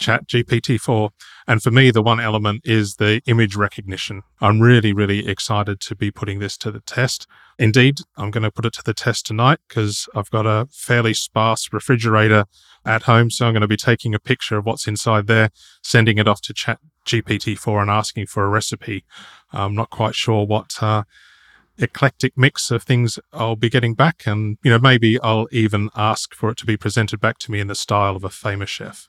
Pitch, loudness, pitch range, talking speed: 110 Hz, -18 LUFS, 105-120 Hz, 210 wpm